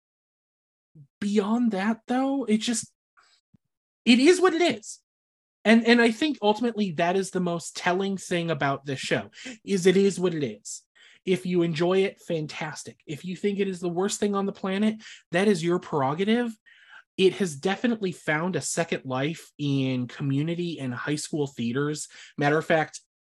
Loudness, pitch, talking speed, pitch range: -25 LUFS, 185 Hz, 170 wpm, 155-210 Hz